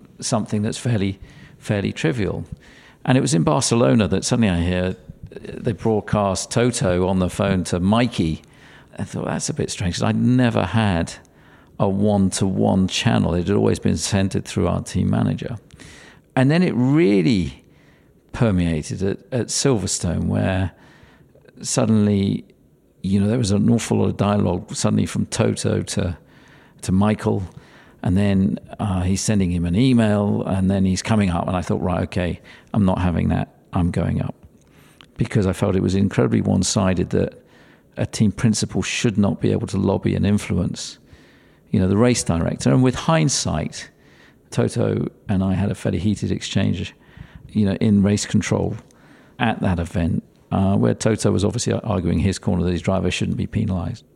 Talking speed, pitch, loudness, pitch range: 165 wpm, 100 Hz, -20 LUFS, 90-110 Hz